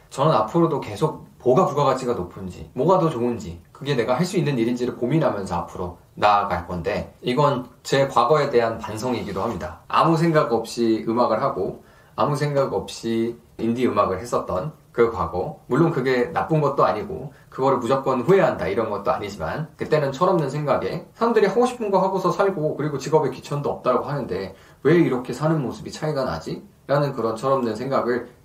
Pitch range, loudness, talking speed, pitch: 115-155 Hz, -22 LUFS, 390 characters per minute, 130 Hz